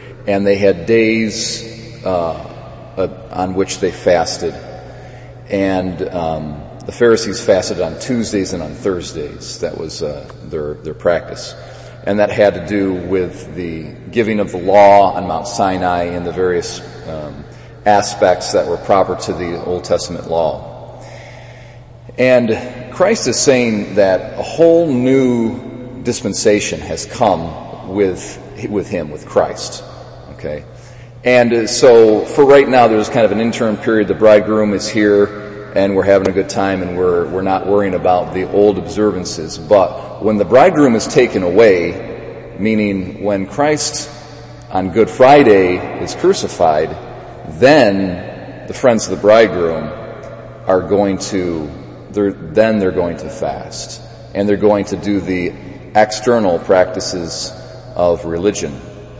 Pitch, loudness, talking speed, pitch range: 105 Hz, -14 LUFS, 140 wpm, 95-115 Hz